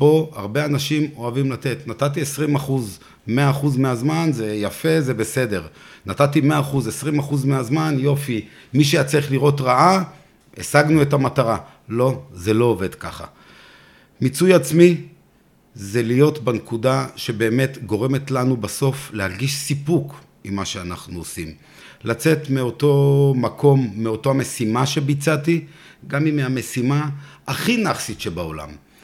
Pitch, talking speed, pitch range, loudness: 135 Hz, 130 wpm, 115-150 Hz, -20 LUFS